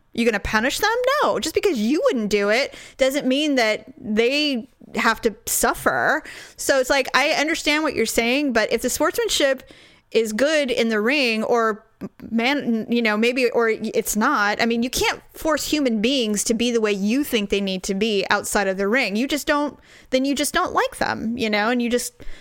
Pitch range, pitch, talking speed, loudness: 220-280 Hz, 240 Hz, 210 wpm, -20 LUFS